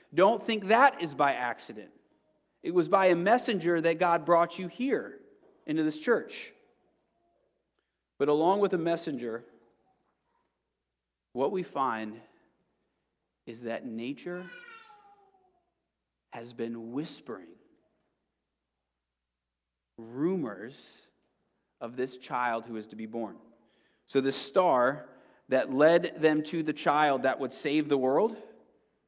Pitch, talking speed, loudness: 155 Hz, 115 wpm, -28 LUFS